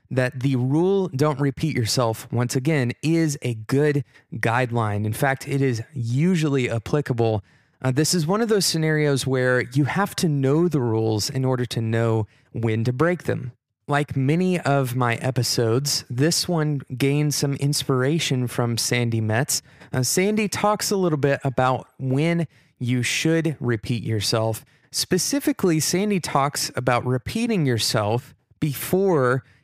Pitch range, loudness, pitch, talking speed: 120-155 Hz, -22 LUFS, 135 Hz, 145 wpm